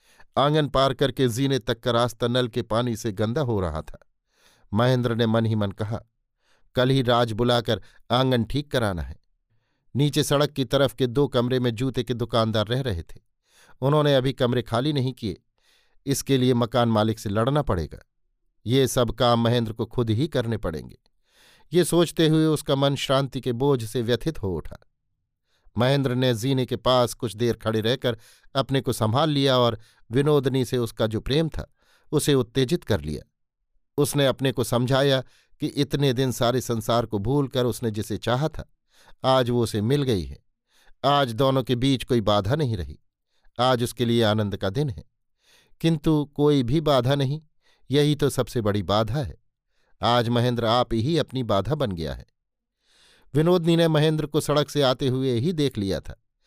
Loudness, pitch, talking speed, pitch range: -23 LUFS, 125 Hz, 180 wpm, 115-140 Hz